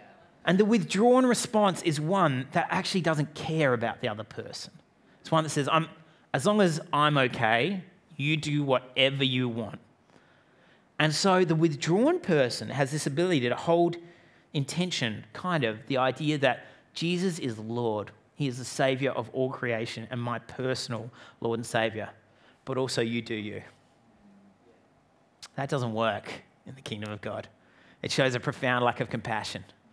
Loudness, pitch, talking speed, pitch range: -28 LUFS, 135 Hz, 160 wpm, 115-165 Hz